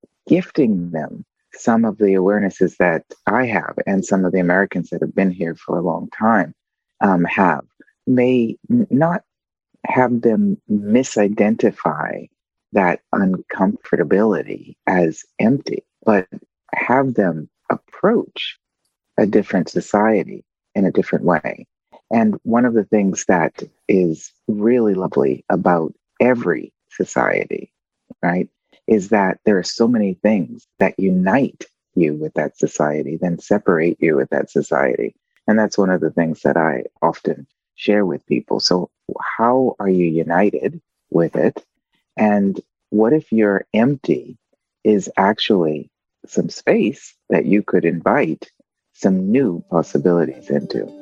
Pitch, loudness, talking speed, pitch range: 100 Hz, -18 LUFS, 130 wpm, 90-115 Hz